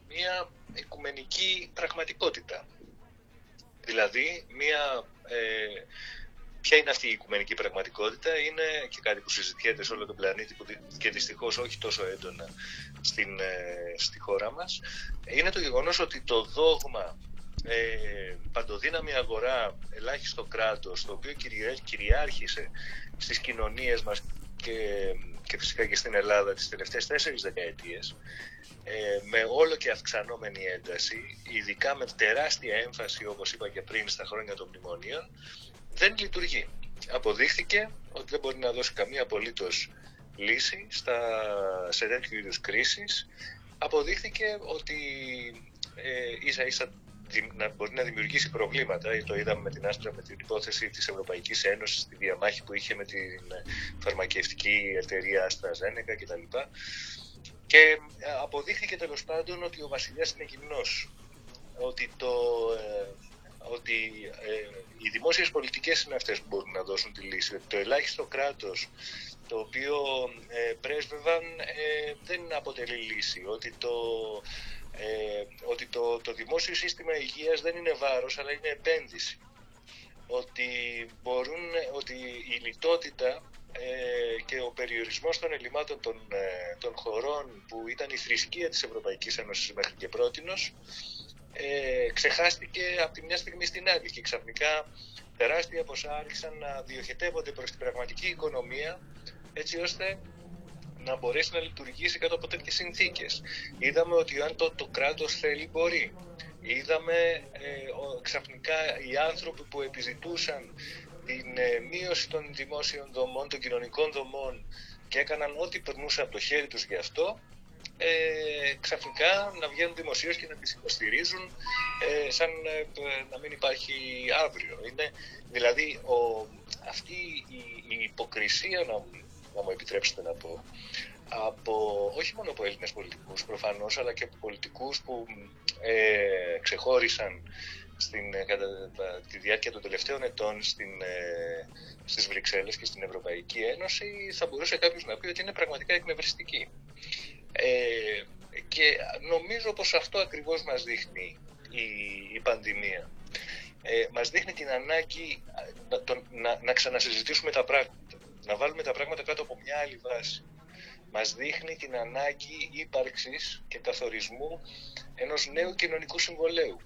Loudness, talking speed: -31 LUFS, 135 wpm